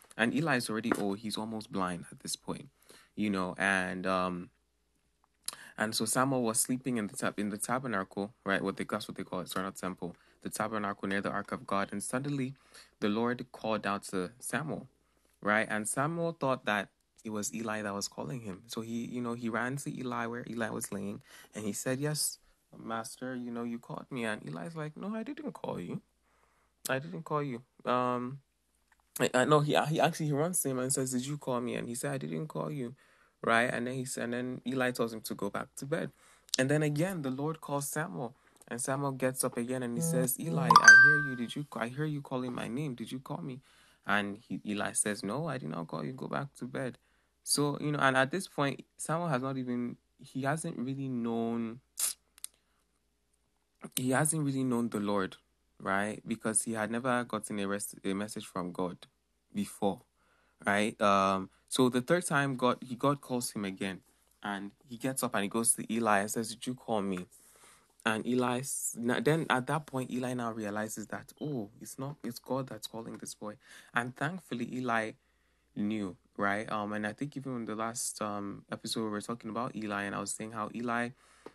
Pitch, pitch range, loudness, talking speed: 115 Hz, 100-130 Hz, -32 LUFS, 210 wpm